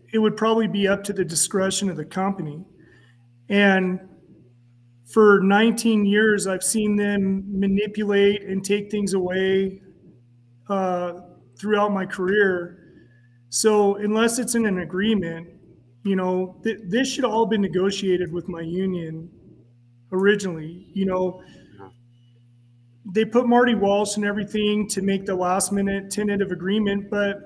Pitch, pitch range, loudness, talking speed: 195 Hz, 175-205 Hz, -22 LUFS, 135 wpm